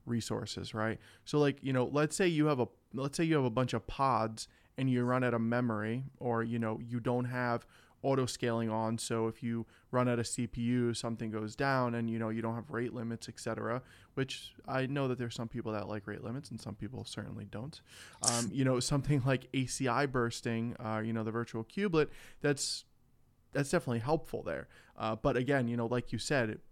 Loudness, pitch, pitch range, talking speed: -35 LUFS, 120 Hz, 115-130 Hz, 215 wpm